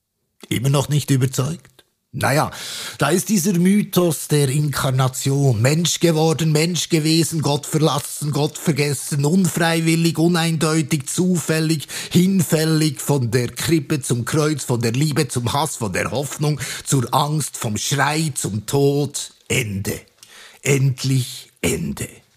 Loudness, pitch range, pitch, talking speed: -19 LUFS, 135-160 Hz, 150 Hz, 120 wpm